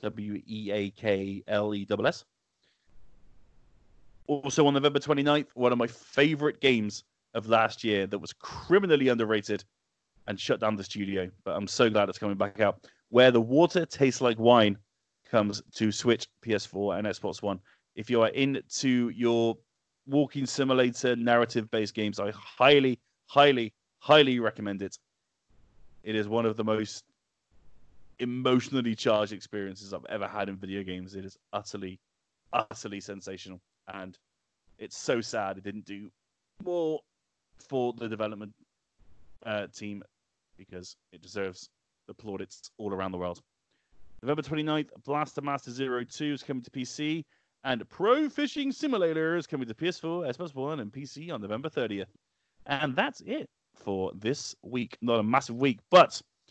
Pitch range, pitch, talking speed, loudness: 100-135 Hz, 115 Hz, 145 wpm, -28 LUFS